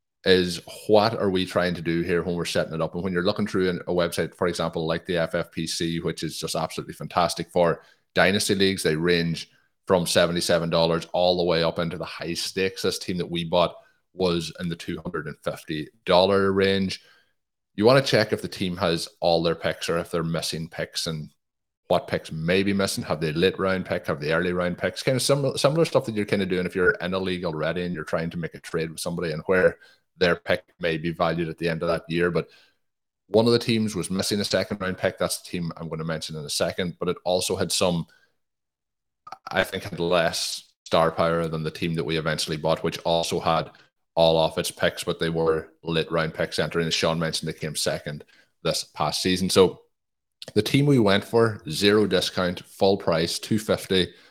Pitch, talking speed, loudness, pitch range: 85 Hz, 220 wpm, -24 LUFS, 80-95 Hz